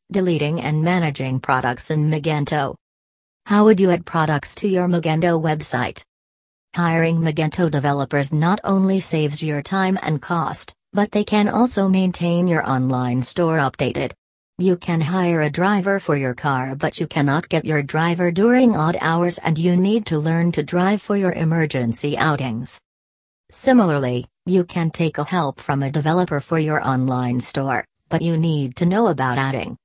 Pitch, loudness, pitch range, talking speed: 160 Hz, -19 LUFS, 140-180 Hz, 165 wpm